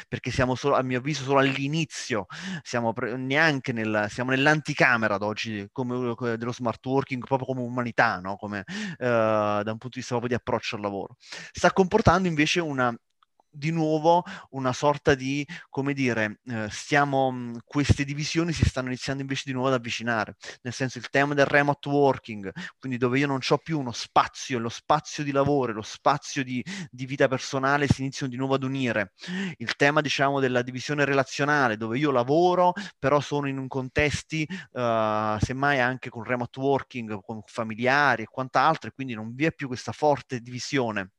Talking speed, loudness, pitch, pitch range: 175 wpm, -26 LUFS, 130 Hz, 120-145 Hz